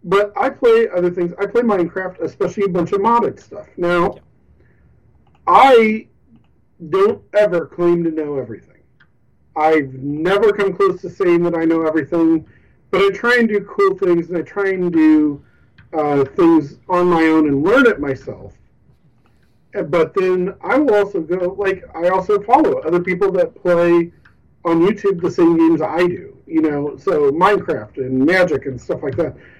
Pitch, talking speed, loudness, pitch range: 175 Hz, 170 wpm, -16 LUFS, 165-200 Hz